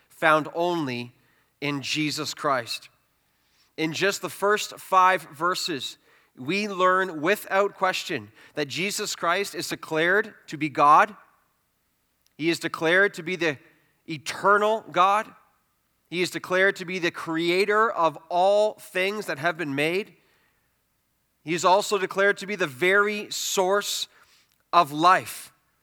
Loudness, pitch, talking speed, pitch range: -24 LUFS, 180 Hz, 130 wpm, 160-195 Hz